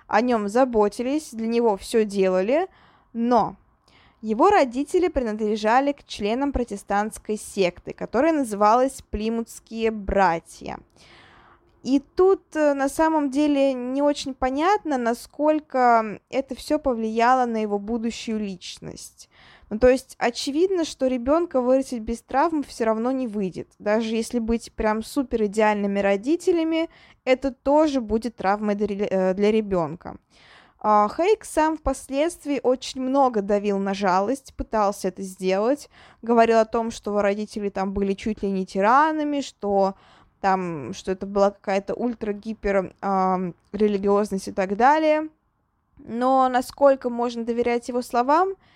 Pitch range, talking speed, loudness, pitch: 205-270 Hz, 125 wpm, -23 LUFS, 230 Hz